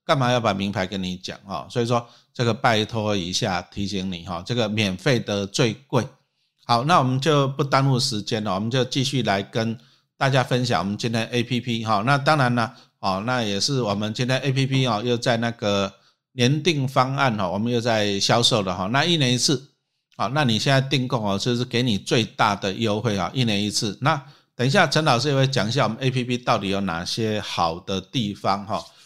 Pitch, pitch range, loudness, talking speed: 120 Hz, 105-130 Hz, -22 LUFS, 305 characters per minute